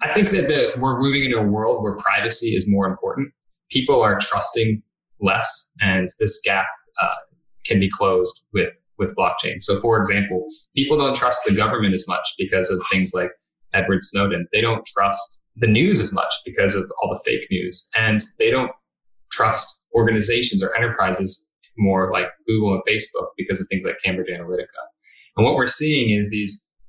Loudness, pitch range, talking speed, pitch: -20 LUFS, 95-120 Hz, 180 wpm, 105 Hz